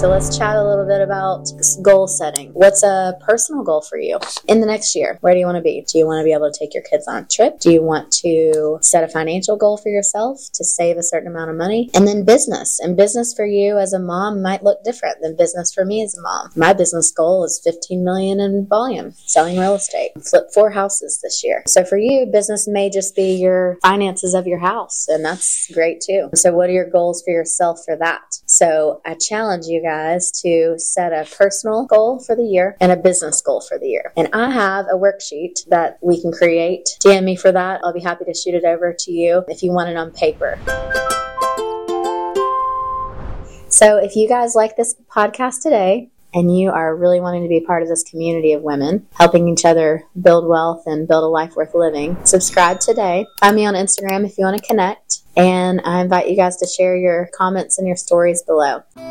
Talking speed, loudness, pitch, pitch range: 225 wpm, -15 LUFS, 180 Hz, 165-205 Hz